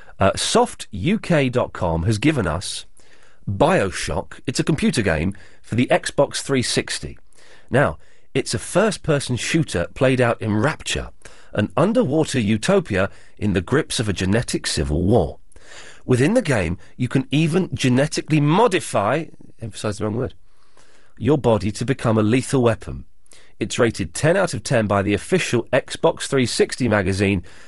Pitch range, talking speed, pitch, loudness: 100-140 Hz, 145 wpm, 115 Hz, -20 LUFS